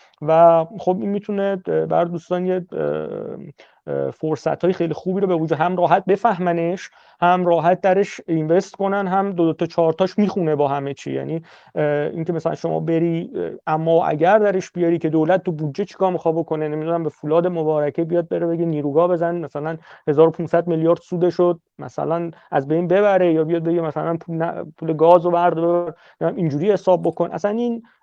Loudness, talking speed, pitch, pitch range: -20 LUFS, 170 wpm, 170 Hz, 160-180 Hz